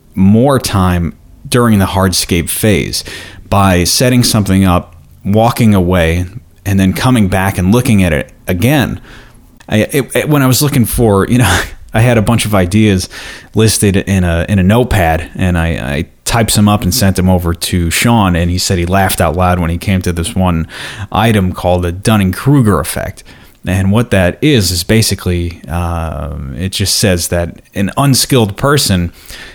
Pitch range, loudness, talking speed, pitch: 90-110 Hz, -11 LUFS, 180 wpm, 95 Hz